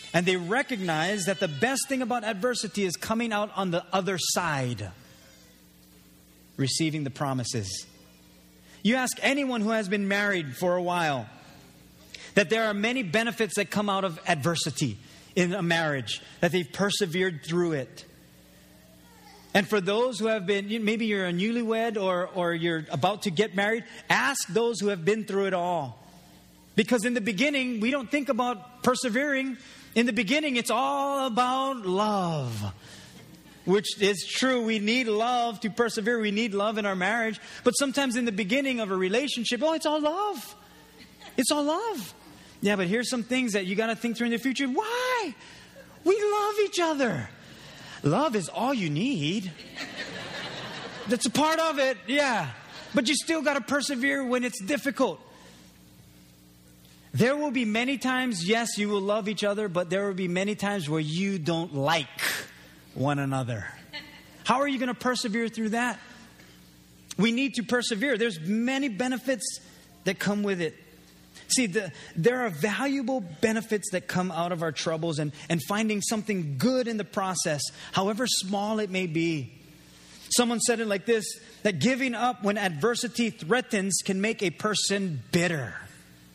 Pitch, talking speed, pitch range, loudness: 205 Hz, 165 wpm, 165-245 Hz, -27 LUFS